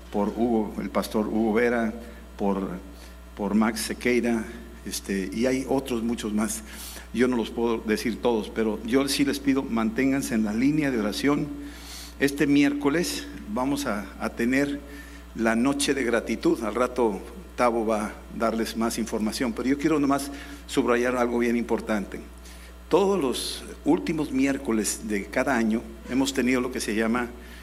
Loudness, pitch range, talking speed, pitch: -26 LUFS, 110-135 Hz, 155 wpm, 115 Hz